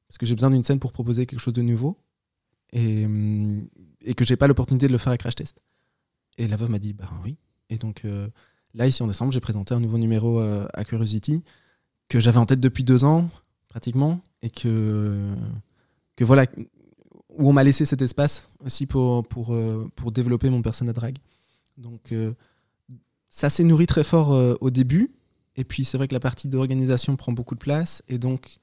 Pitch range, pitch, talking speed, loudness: 115-135 Hz, 125 Hz, 205 wpm, -22 LUFS